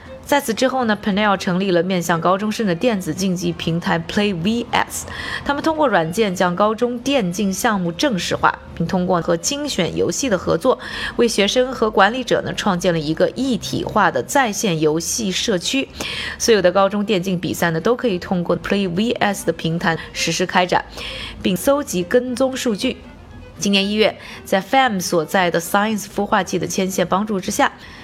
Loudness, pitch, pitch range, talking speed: -19 LUFS, 200 Hz, 180-235 Hz, 310 characters per minute